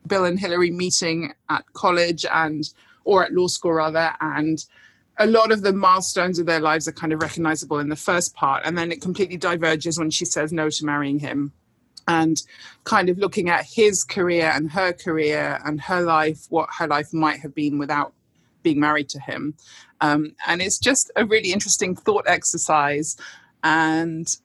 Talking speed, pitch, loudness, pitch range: 185 wpm, 165 Hz, -21 LUFS, 155-180 Hz